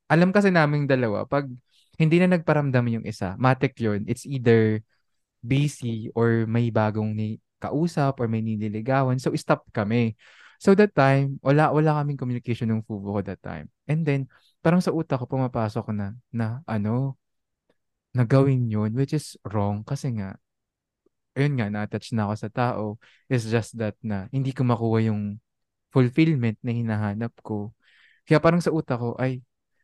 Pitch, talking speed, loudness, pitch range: 120 Hz, 160 wpm, -24 LUFS, 110-140 Hz